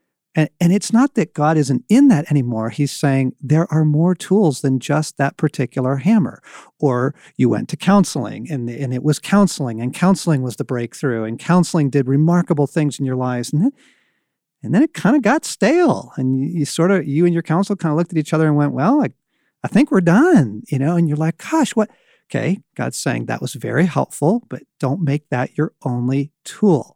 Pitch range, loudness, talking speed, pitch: 140-190 Hz, -18 LUFS, 220 wpm, 155 Hz